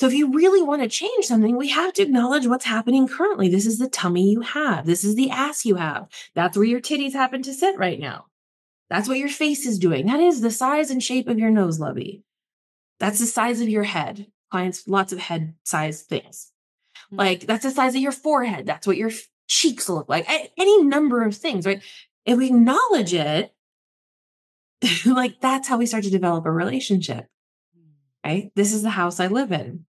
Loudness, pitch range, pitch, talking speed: -21 LUFS, 185-265 Hz, 225 Hz, 205 wpm